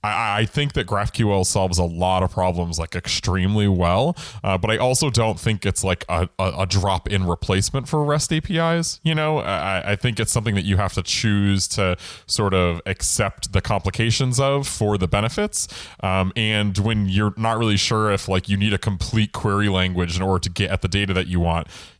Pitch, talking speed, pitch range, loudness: 100 Hz, 205 wpm, 95-115 Hz, -21 LUFS